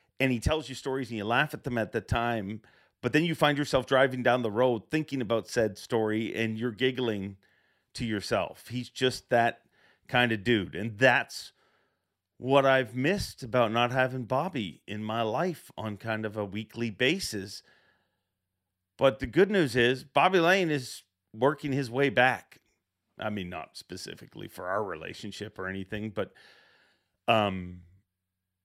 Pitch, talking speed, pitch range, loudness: 115 Hz, 165 wpm, 105-130 Hz, -28 LUFS